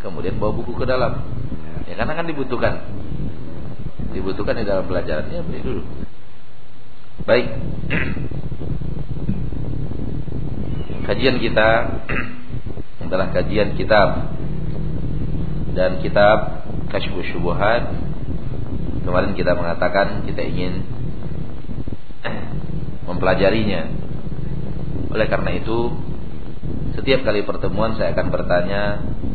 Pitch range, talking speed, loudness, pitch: 90-115 Hz, 80 wpm, -22 LUFS, 100 Hz